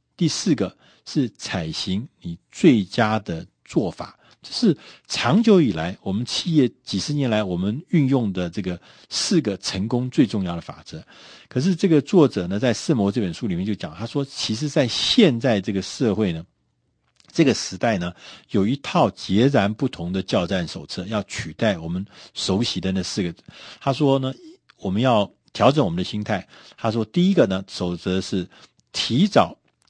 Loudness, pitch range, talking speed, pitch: -22 LUFS, 95-140 Hz, 250 characters per minute, 105 Hz